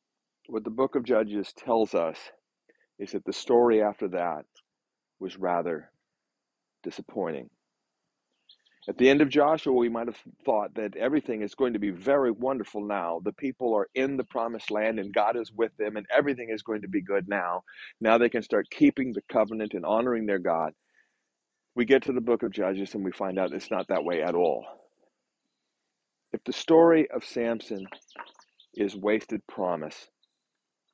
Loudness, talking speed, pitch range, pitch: -27 LUFS, 175 wpm, 105-130 Hz, 115 Hz